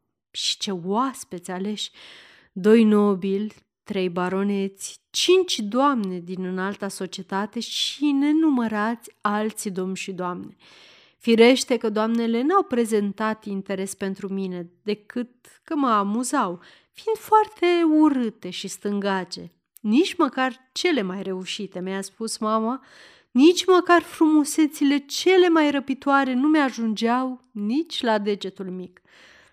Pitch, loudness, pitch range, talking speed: 220 Hz, -22 LUFS, 195-275 Hz, 115 wpm